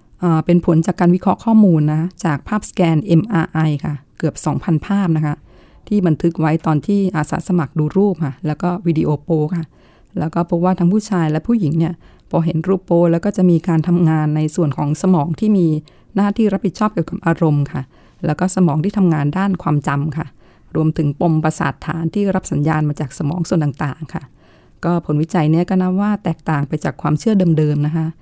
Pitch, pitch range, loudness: 165 Hz, 155-180 Hz, -17 LUFS